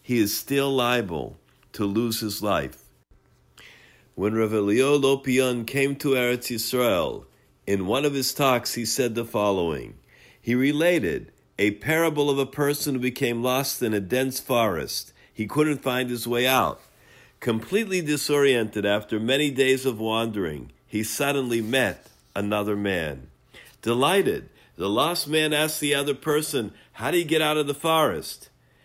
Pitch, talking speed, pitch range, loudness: 130 Hz, 150 wpm, 110-145 Hz, -24 LUFS